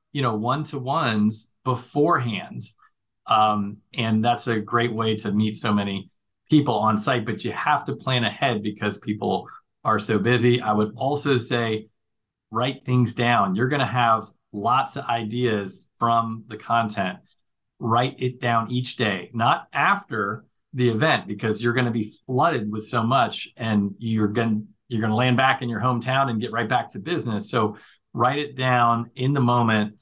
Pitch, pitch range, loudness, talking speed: 115 Hz, 110-125 Hz, -23 LUFS, 180 wpm